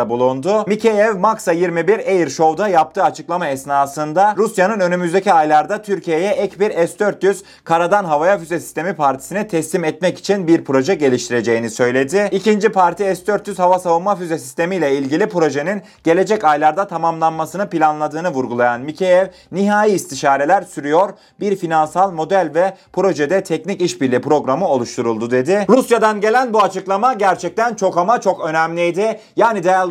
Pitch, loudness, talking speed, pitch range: 180 Hz, -16 LUFS, 135 wpm, 155-200 Hz